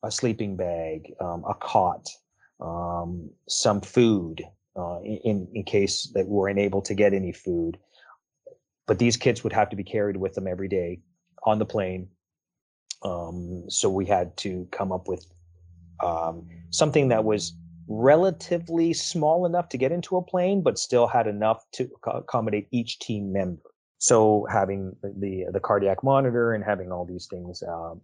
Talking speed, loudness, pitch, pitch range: 165 wpm, -25 LUFS, 100 Hz, 90-120 Hz